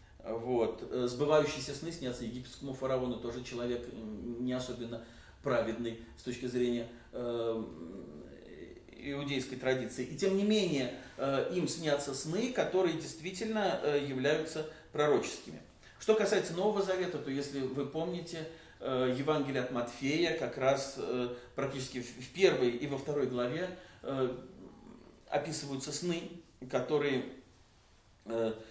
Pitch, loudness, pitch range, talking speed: 135 Hz, -35 LUFS, 120-155 Hz, 120 wpm